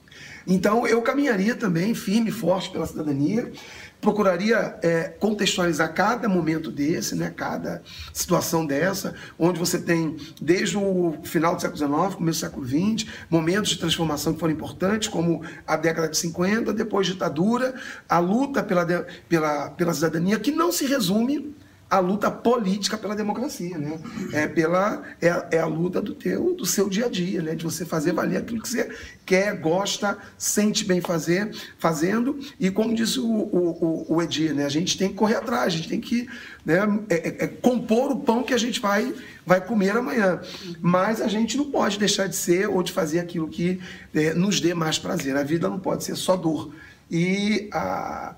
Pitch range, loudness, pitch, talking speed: 165-215 Hz, -24 LUFS, 185 Hz, 180 wpm